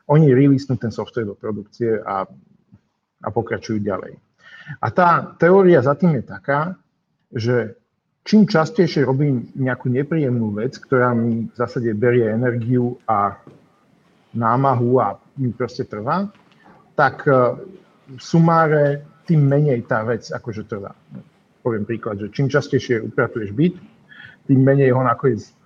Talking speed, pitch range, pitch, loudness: 130 wpm, 115-155 Hz, 130 Hz, -19 LUFS